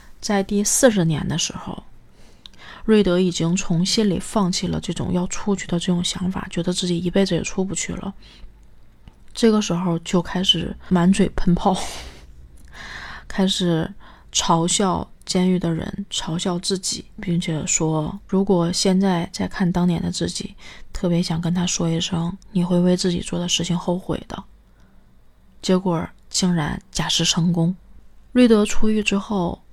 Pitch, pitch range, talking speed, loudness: 180 Hz, 170-195 Hz, 225 characters per minute, -21 LUFS